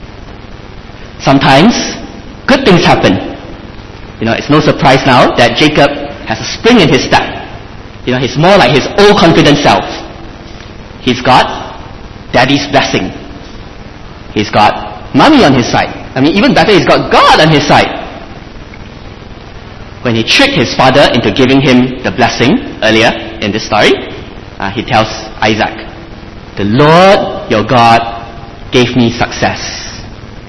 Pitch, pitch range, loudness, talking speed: 115 Hz, 105-130 Hz, -8 LUFS, 140 wpm